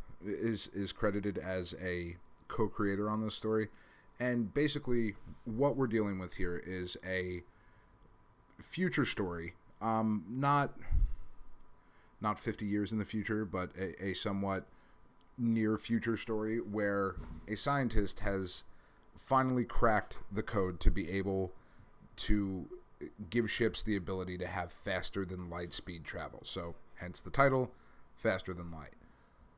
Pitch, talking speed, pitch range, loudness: 105 Hz, 130 wpm, 95-115 Hz, -36 LUFS